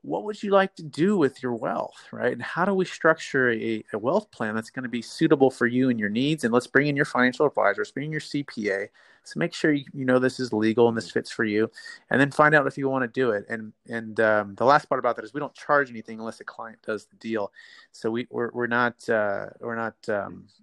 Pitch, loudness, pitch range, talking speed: 125 Hz, -25 LUFS, 115-145 Hz, 270 wpm